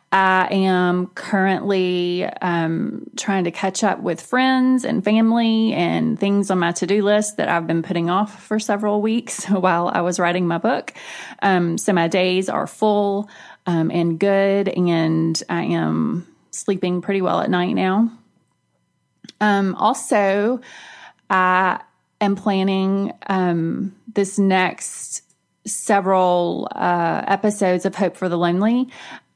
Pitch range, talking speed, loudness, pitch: 180-210 Hz, 135 wpm, -19 LUFS, 195 Hz